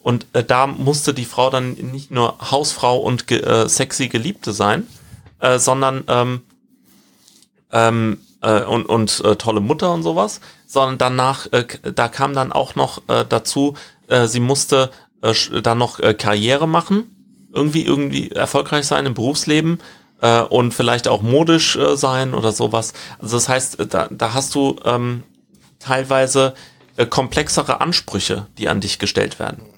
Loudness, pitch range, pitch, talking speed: -17 LUFS, 115-140 Hz, 130 Hz, 160 wpm